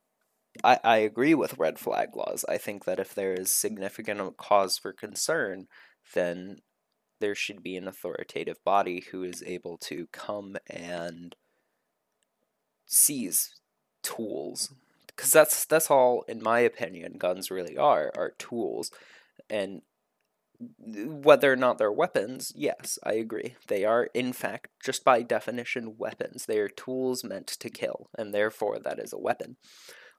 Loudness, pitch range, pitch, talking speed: -28 LUFS, 95-135 Hz, 110 Hz, 145 wpm